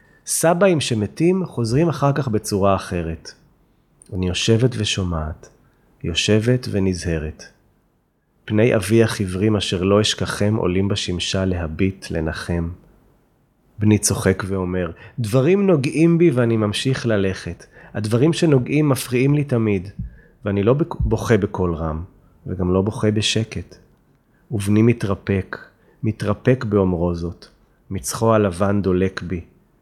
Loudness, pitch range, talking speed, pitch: -19 LUFS, 95-120 Hz, 110 wpm, 105 Hz